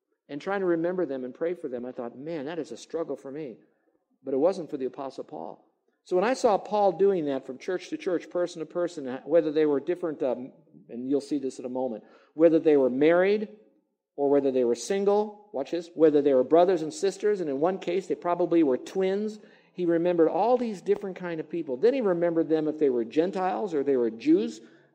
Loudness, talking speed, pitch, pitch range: -26 LUFS, 230 wpm, 170 Hz, 140-190 Hz